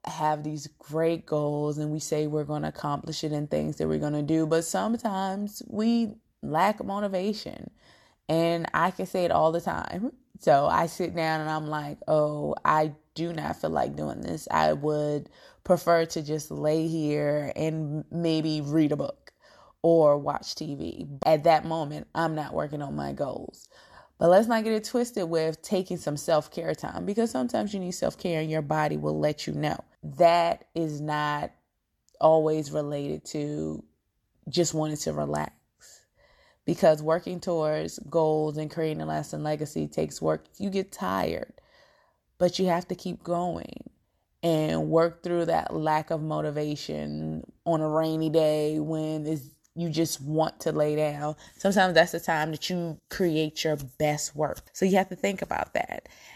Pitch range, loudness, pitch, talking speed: 150-170 Hz, -27 LUFS, 155 Hz, 170 wpm